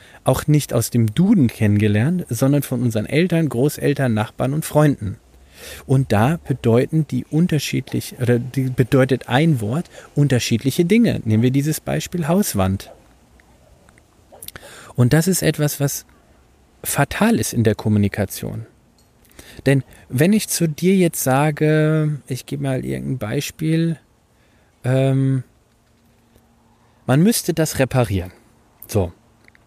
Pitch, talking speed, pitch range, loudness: 130 Hz, 120 wpm, 115-150 Hz, -19 LUFS